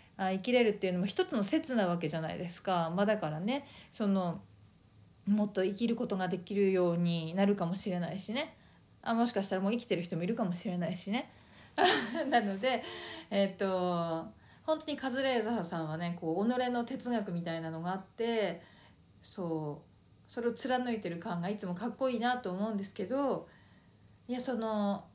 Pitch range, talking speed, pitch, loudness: 175-235 Hz, 360 characters per minute, 200 Hz, -34 LUFS